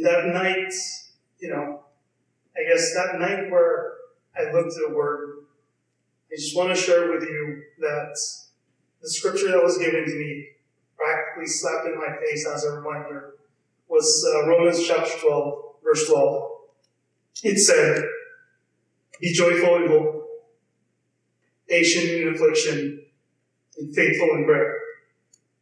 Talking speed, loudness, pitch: 135 wpm, -22 LUFS, 180 Hz